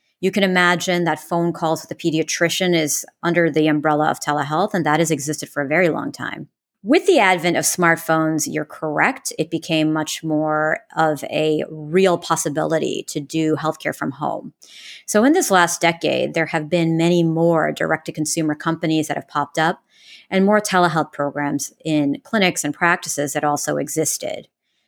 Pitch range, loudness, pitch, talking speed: 155-175 Hz, -19 LUFS, 160 Hz, 175 wpm